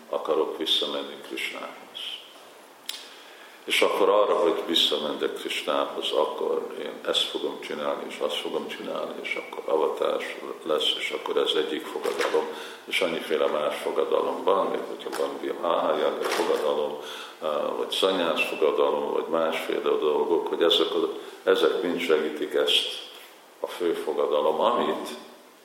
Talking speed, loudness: 130 wpm, -26 LUFS